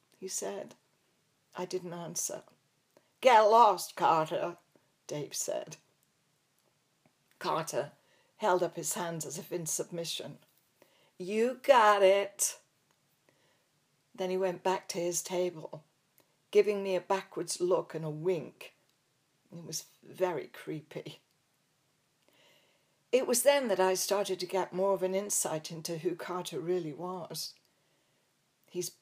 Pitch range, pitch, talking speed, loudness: 170-195 Hz, 180 Hz, 120 wpm, -31 LUFS